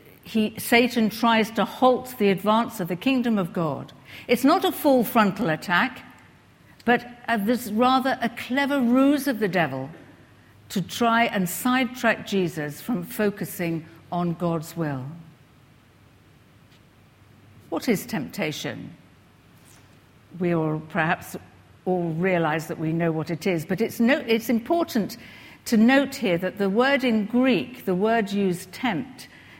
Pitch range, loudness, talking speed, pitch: 165-240 Hz, -23 LUFS, 140 wpm, 205 Hz